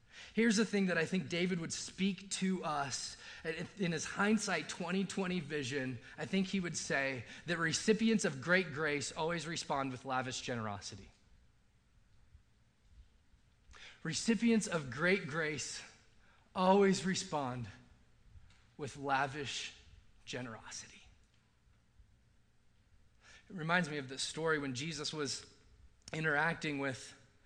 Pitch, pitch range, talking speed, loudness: 155 Hz, 135-185 Hz, 110 wpm, -36 LUFS